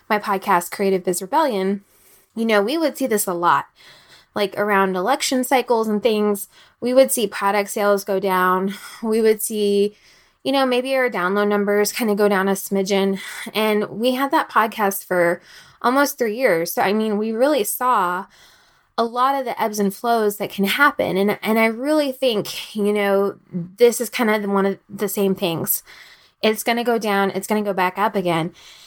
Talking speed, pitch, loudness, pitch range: 190 wpm, 205 Hz, -20 LUFS, 195-235 Hz